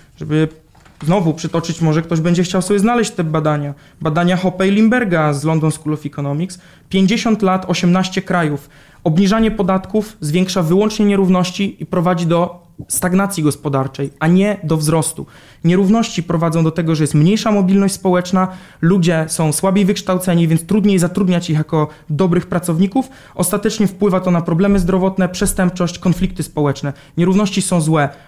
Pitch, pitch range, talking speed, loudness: 180 Hz, 160-190 Hz, 145 wpm, -16 LUFS